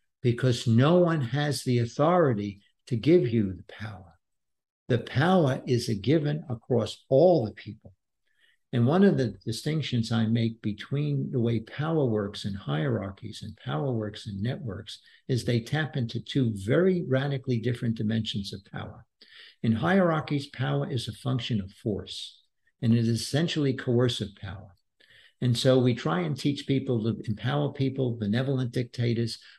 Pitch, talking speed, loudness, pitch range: 120 Hz, 155 wpm, -27 LUFS, 110-140 Hz